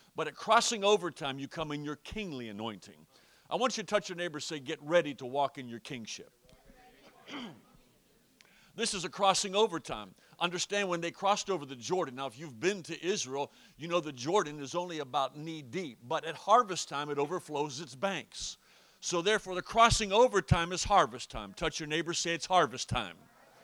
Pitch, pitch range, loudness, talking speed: 170 Hz, 145-195 Hz, -32 LUFS, 200 wpm